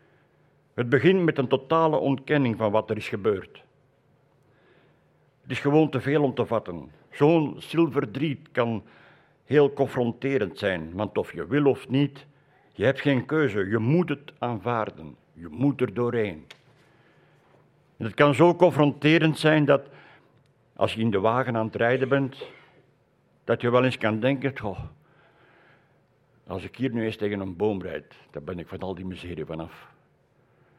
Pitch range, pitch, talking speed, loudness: 115-145 Hz, 135 Hz, 160 wpm, -25 LUFS